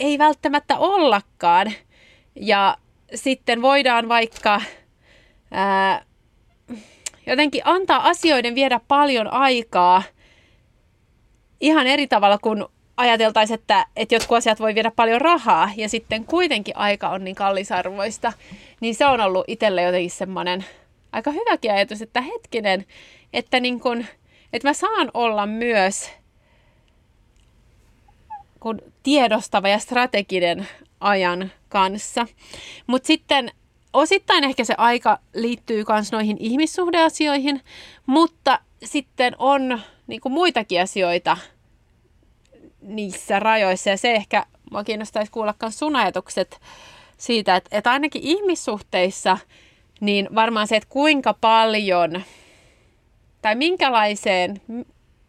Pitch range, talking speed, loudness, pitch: 200-275 Hz, 105 wpm, -20 LUFS, 225 Hz